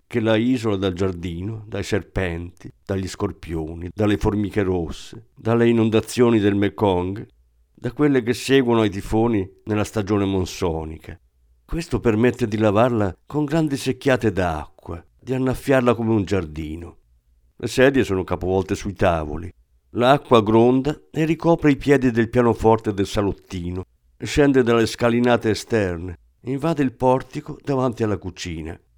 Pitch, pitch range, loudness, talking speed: 110 Hz, 90-125 Hz, -21 LUFS, 135 wpm